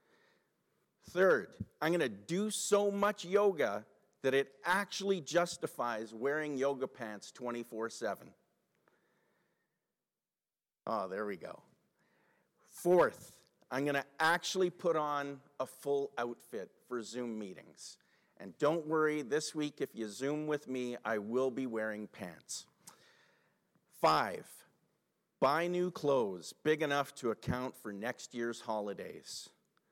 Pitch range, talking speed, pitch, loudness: 120-170 Hz, 120 wpm, 140 Hz, -35 LUFS